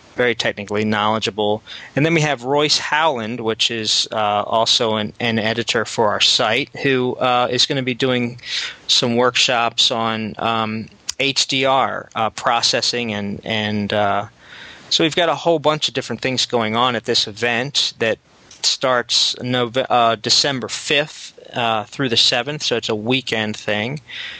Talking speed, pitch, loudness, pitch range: 165 wpm, 120 Hz, -18 LUFS, 110-130 Hz